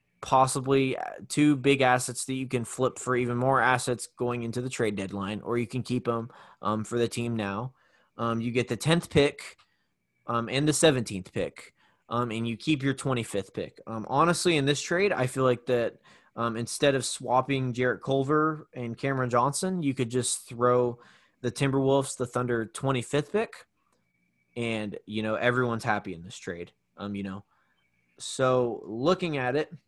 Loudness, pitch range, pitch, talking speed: -28 LUFS, 115-135 Hz, 125 Hz, 175 wpm